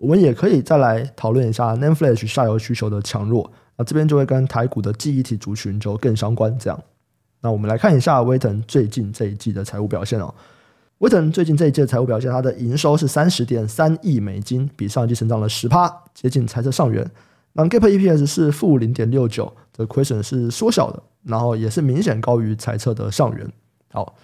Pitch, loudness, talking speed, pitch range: 120 Hz, -19 LUFS, 335 characters per minute, 110-145 Hz